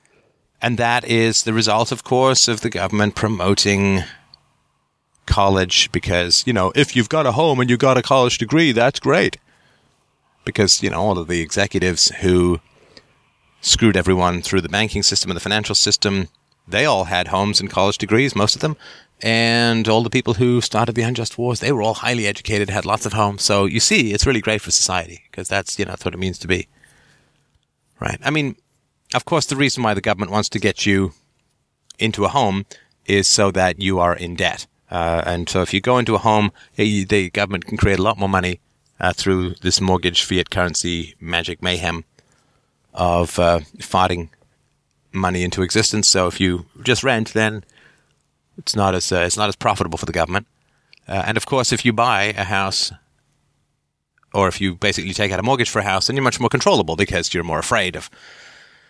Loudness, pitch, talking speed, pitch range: -18 LUFS, 100 Hz, 200 wpm, 90-115 Hz